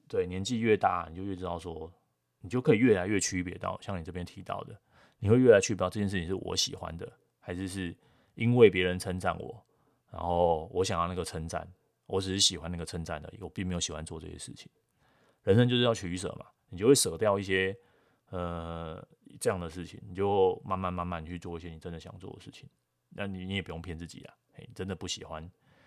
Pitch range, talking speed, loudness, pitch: 85-95 Hz, 320 characters per minute, -30 LUFS, 90 Hz